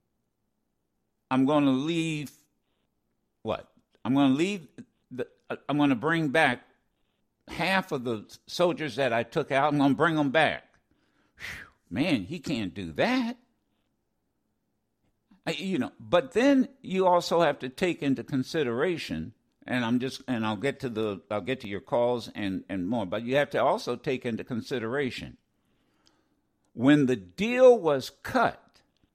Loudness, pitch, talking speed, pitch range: -27 LUFS, 140 Hz, 155 wpm, 125-170 Hz